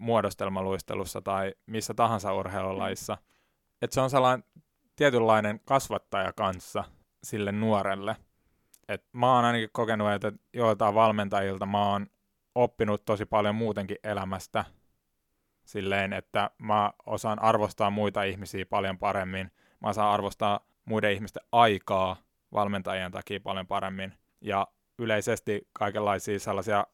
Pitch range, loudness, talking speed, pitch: 95-110 Hz, -29 LUFS, 115 wpm, 105 Hz